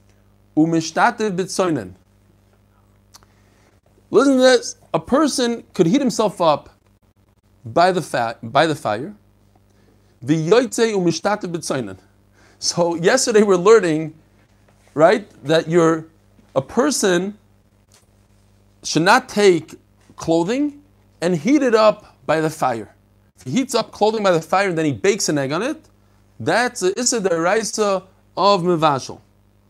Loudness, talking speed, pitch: -18 LUFS, 110 wpm, 155 Hz